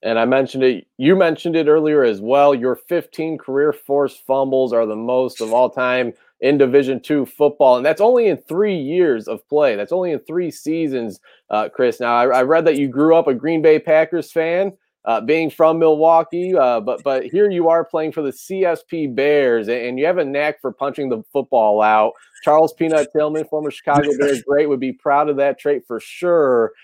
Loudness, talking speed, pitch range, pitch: -17 LUFS, 210 wpm, 130-165 Hz, 145 Hz